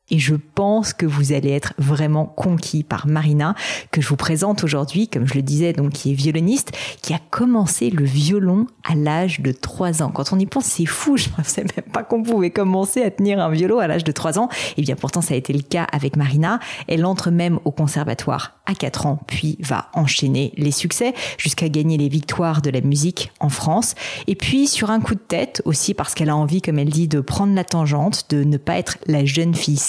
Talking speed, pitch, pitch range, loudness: 230 wpm, 160 Hz, 145-190 Hz, -19 LUFS